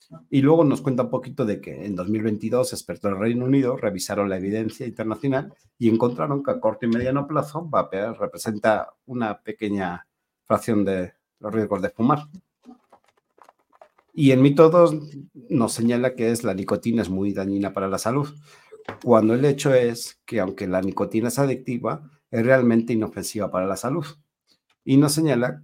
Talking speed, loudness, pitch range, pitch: 165 wpm, -22 LUFS, 105-140 Hz, 120 Hz